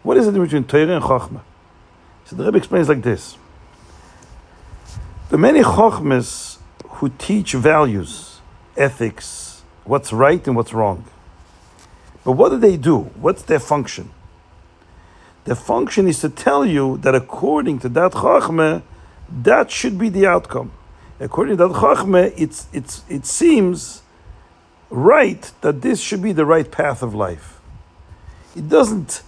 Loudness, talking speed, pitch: -16 LUFS, 145 wpm, 125 Hz